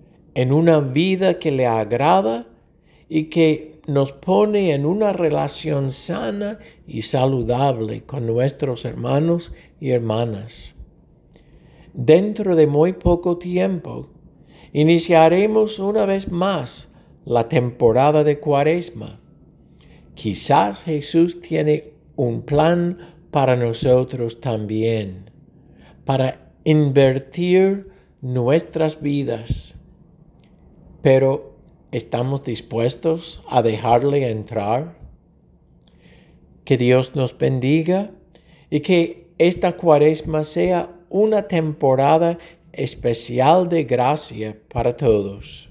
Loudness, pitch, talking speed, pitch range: -19 LUFS, 150 Hz, 90 wpm, 125-170 Hz